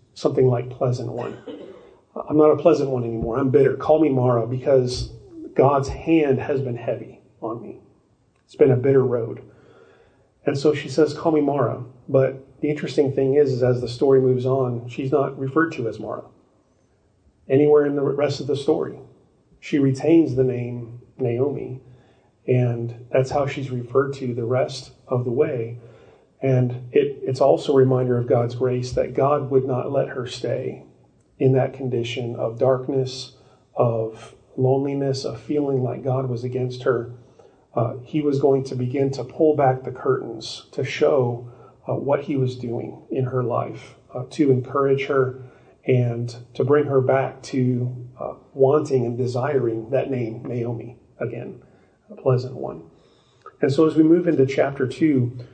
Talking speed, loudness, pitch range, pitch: 165 wpm, -21 LUFS, 125-140 Hz, 130 Hz